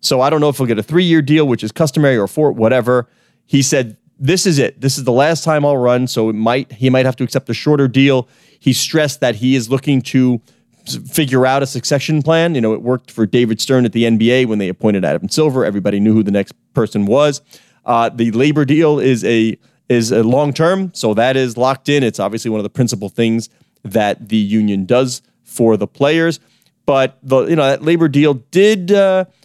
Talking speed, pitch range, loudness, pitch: 230 wpm, 115-150 Hz, -14 LUFS, 130 Hz